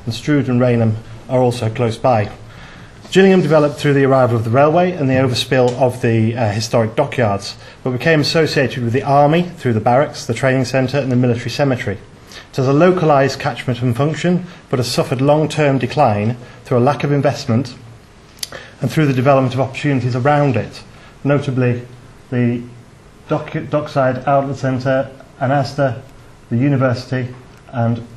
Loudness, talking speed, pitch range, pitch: -16 LUFS, 160 wpm, 120-145 Hz, 130 Hz